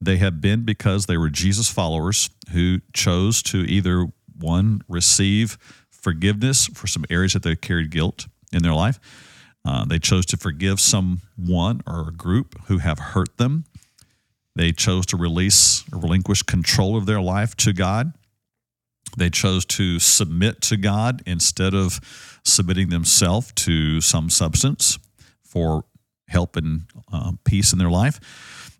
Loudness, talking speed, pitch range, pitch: -19 LUFS, 150 wpm, 85-110 Hz, 95 Hz